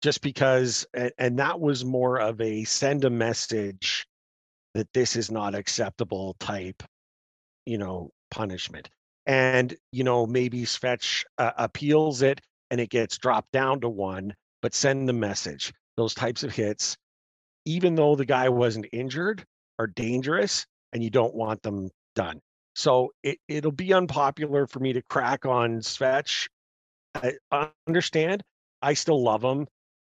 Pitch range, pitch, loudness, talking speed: 110-140 Hz, 125 Hz, -26 LUFS, 150 wpm